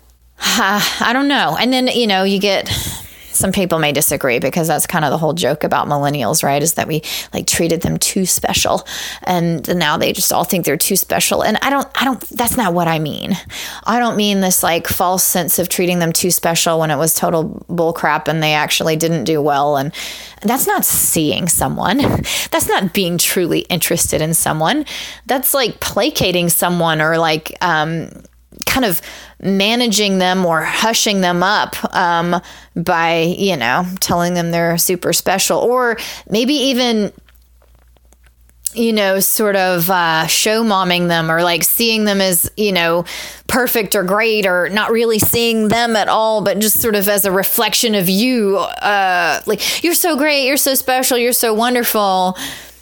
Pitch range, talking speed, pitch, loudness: 165-225 Hz, 180 wpm, 185 Hz, -14 LUFS